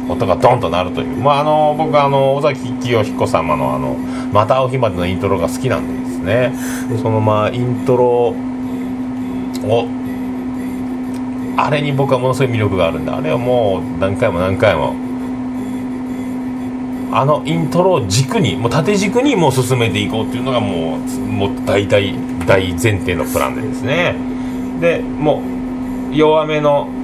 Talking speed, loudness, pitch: 295 characters per minute, -16 LUFS, 135 Hz